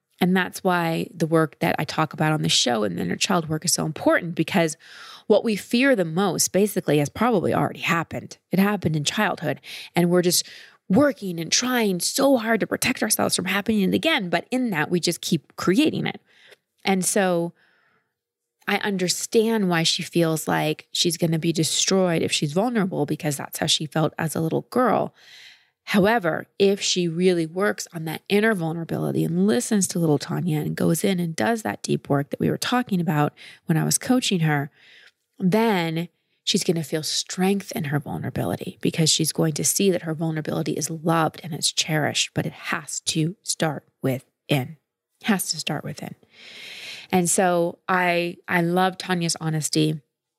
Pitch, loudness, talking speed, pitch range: 175 Hz, -22 LUFS, 185 wpm, 160-195 Hz